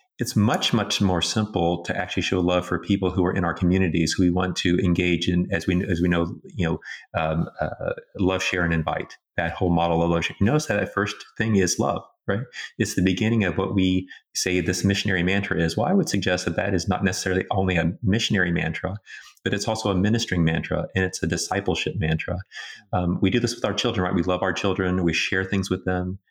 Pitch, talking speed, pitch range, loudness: 95 Hz, 230 wpm, 90-100 Hz, -23 LUFS